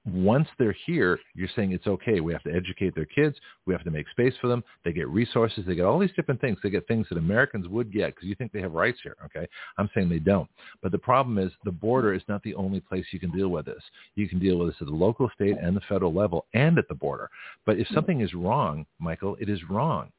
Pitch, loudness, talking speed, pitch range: 100 Hz, -27 LUFS, 265 wpm, 90-115 Hz